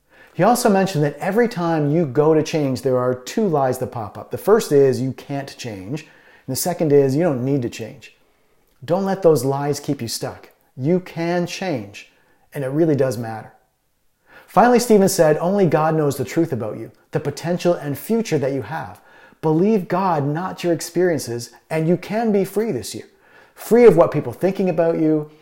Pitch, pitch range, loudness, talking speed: 155 Hz, 135-180 Hz, -19 LUFS, 195 wpm